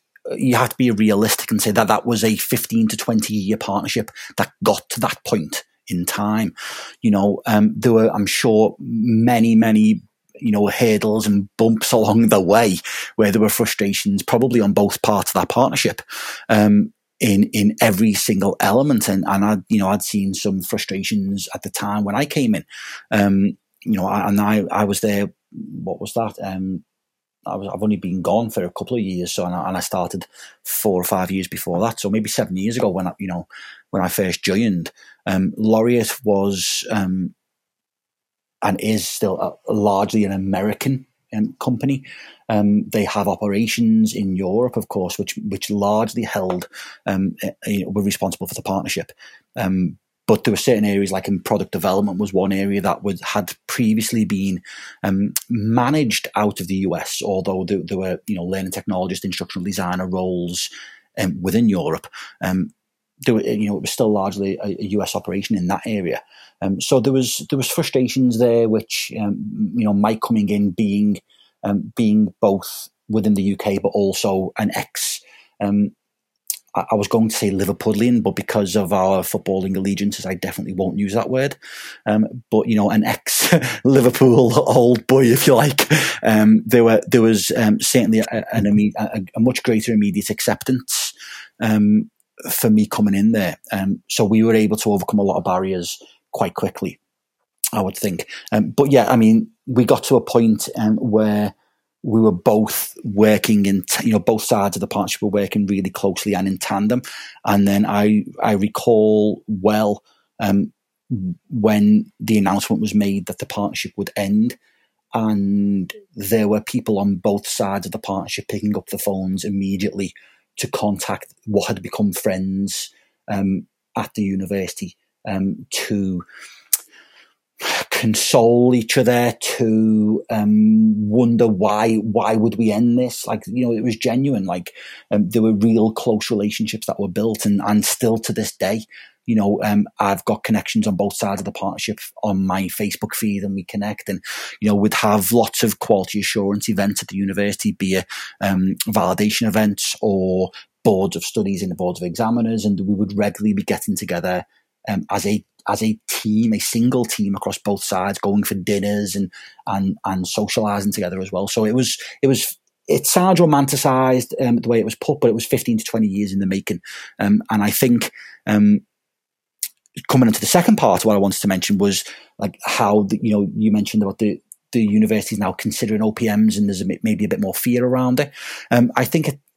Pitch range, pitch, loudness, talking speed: 100-115 Hz, 105 Hz, -19 LUFS, 185 wpm